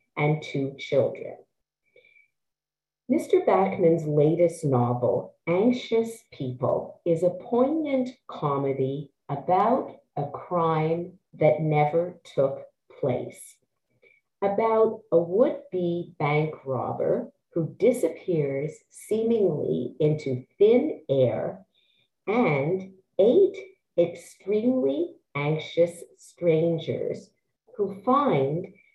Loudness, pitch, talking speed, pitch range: -25 LUFS, 170 Hz, 80 wpm, 150-225 Hz